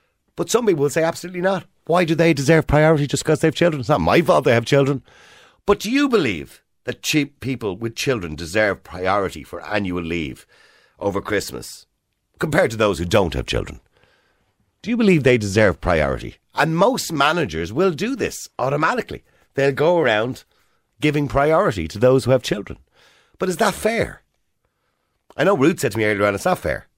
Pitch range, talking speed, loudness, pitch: 105-160 Hz, 190 wpm, -19 LUFS, 135 Hz